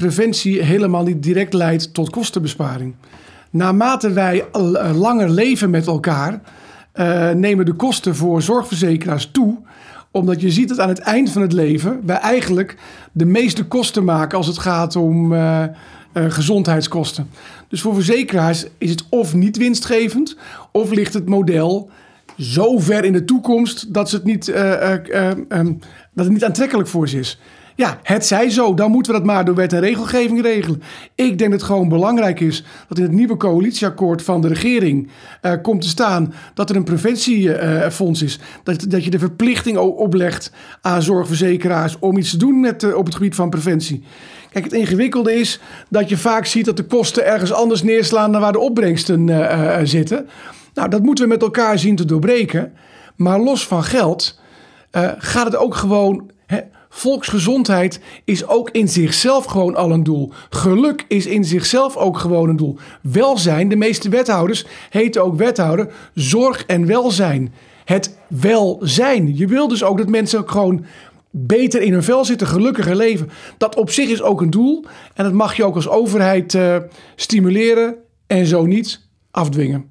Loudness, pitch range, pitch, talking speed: -16 LUFS, 170-225 Hz, 195 Hz, 175 wpm